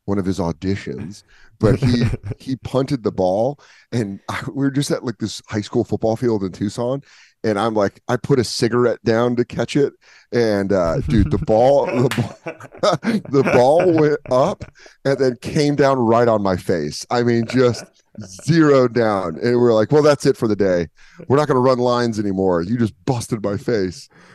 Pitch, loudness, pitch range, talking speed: 120 Hz, -18 LUFS, 105-130 Hz, 190 wpm